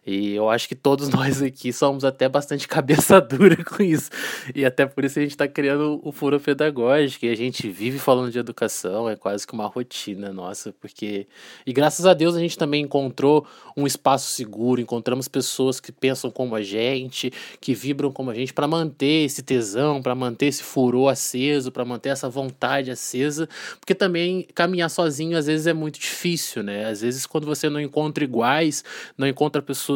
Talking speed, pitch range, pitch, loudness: 190 wpm, 125-150 Hz, 140 Hz, -22 LUFS